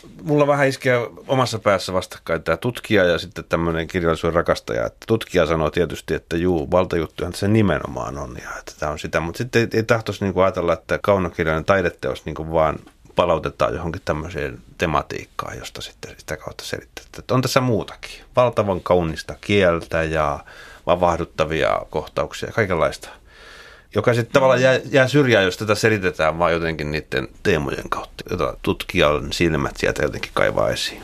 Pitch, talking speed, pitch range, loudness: 90 Hz, 155 wpm, 80-115 Hz, -20 LUFS